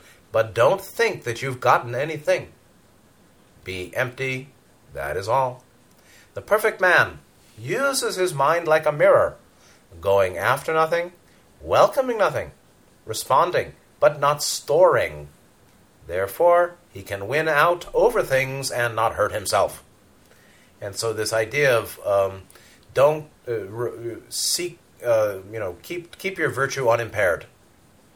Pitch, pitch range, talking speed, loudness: 135 Hz, 110-175 Hz, 125 wpm, -22 LUFS